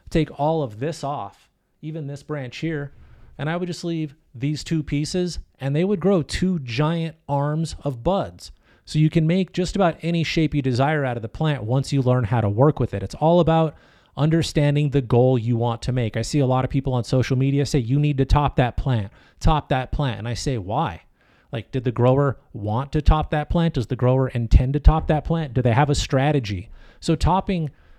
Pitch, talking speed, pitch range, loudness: 145 Hz, 225 wpm, 125-160 Hz, -22 LUFS